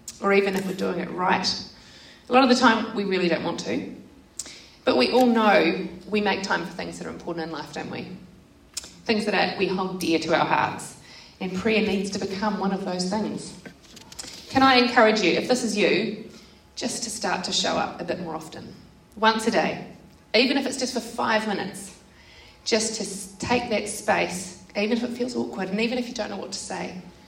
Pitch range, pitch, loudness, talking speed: 185-230 Hz, 205 Hz, -24 LUFS, 215 wpm